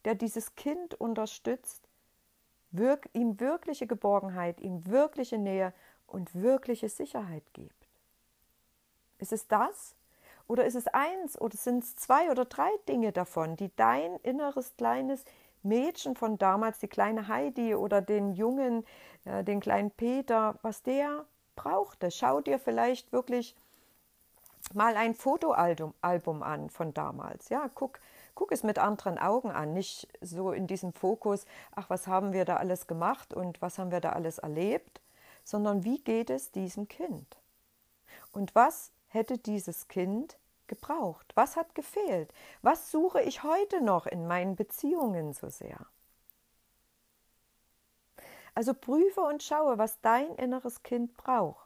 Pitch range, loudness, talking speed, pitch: 190-260 Hz, -31 LUFS, 140 wpm, 225 Hz